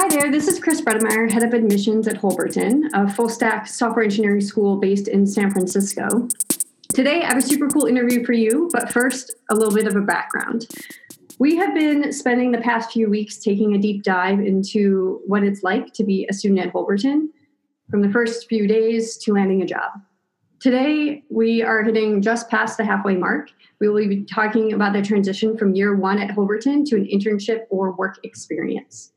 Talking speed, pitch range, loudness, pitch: 195 wpm, 200-245 Hz, -19 LUFS, 220 Hz